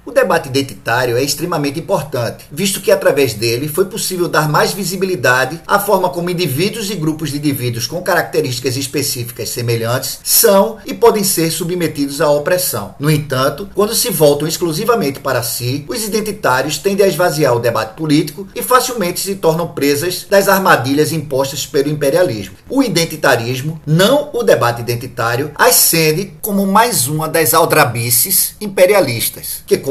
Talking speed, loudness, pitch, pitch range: 150 wpm, -14 LUFS, 160 Hz, 140-195 Hz